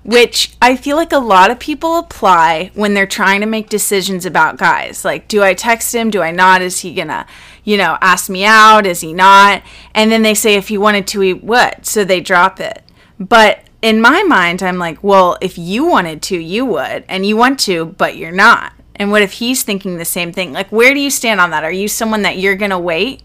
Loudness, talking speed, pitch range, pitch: -11 LUFS, 240 wpm, 185-225 Hz, 205 Hz